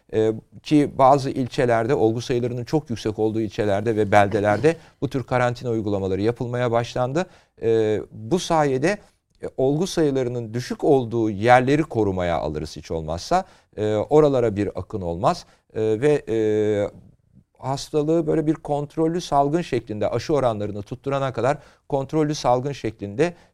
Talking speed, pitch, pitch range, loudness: 115 wpm, 120 Hz, 110-145 Hz, -22 LUFS